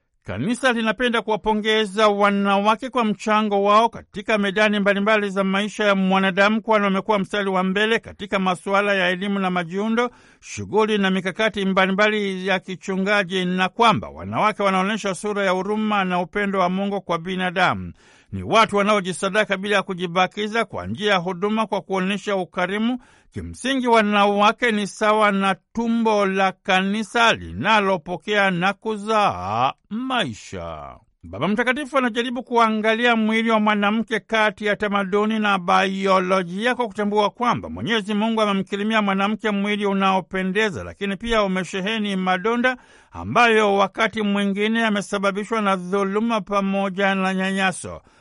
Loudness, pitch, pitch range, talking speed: -20 LUFS, 205 Hz, 195-220 Hz, 130 wpm